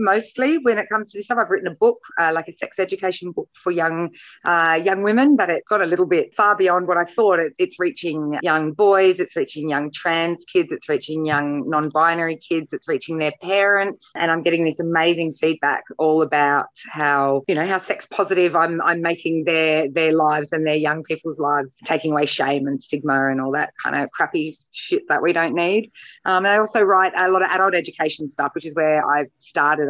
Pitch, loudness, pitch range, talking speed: 170 Hz, -19 LUFS, 155-195 Hz, 220 wpm